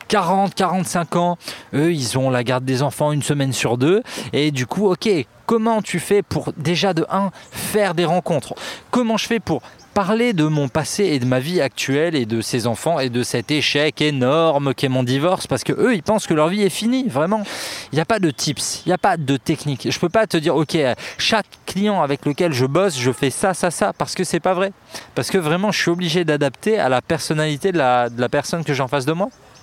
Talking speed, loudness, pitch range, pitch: 245 wpm, -19 LUFS, 140-195 Hz, 165 Hz